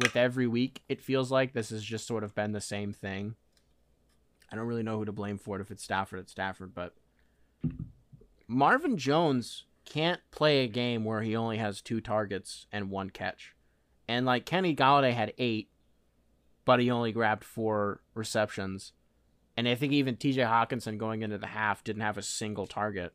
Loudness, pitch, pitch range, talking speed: -31 LUFS, 110 Hz, 95-120 Hz, 185 wpm